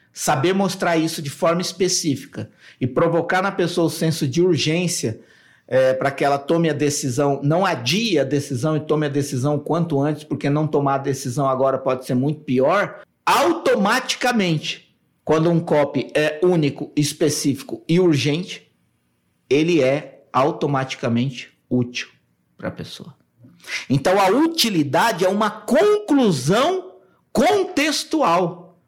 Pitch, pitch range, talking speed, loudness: 155 Hz, 140-180 Hz, 135 wpm, -20 LUFS